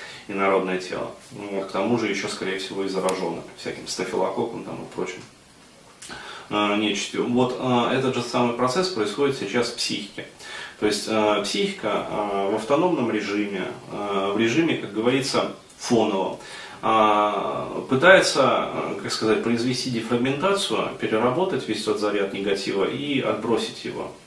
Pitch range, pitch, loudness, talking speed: 100-125 Hz, 105 Hz, -23 LUFS, 140 wpm